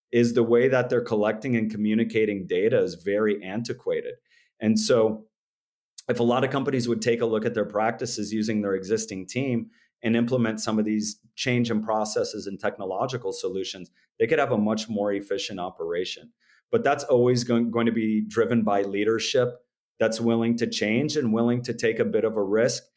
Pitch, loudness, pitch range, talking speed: 115 Hz, -25 LUFS, 110-125 Hz, 185 wpm